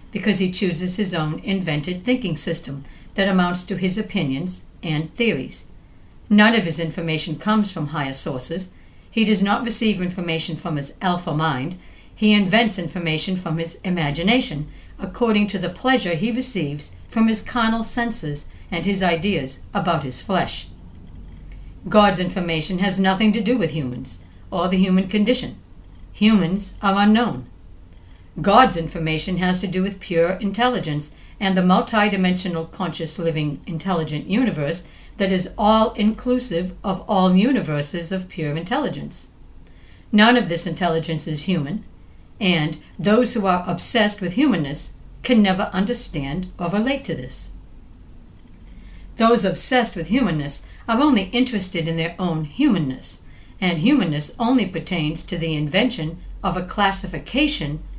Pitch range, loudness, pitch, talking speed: 155-210 Hz, -21 LUFS, 180 Hz, 140 wpm